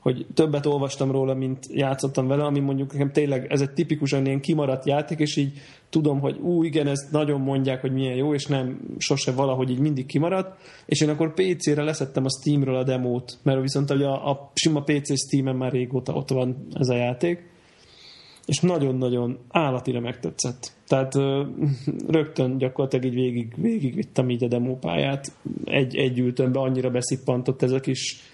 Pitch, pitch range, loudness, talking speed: 135 Hz, 130-150 Hz, -24 LUFS, 170 wpm